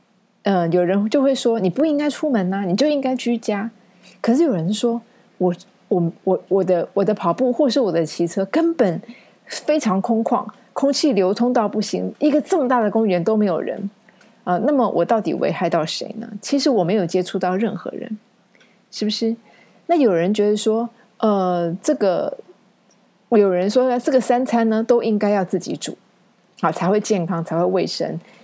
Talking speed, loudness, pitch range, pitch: 270 characters per minute, -19 LUFS, 190-245 Hz, 215 Hz